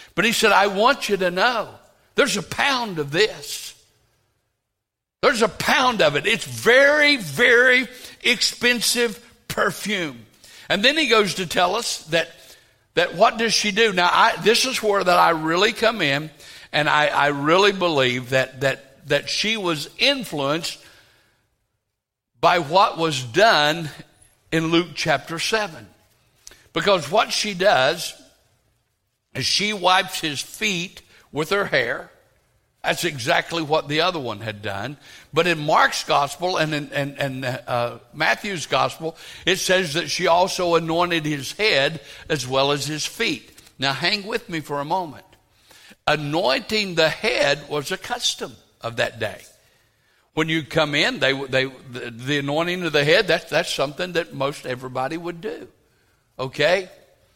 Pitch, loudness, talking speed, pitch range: 160 Hz, -20 LUFS, 155 wpm, 135-185 Hz